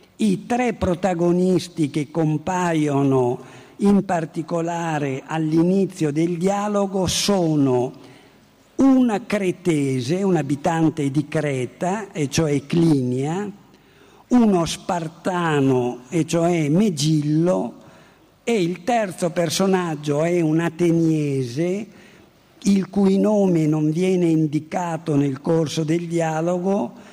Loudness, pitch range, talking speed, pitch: -21 LUFS, 155-190 Hz, 95 wpm, 170 Hz